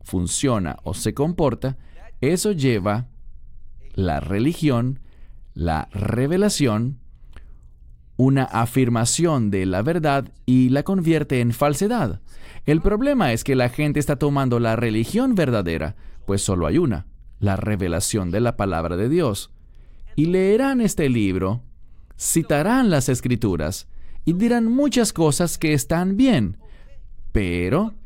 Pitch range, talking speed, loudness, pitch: 95-155 Hz, 120 wpm, -21 LUFS, 120 Hz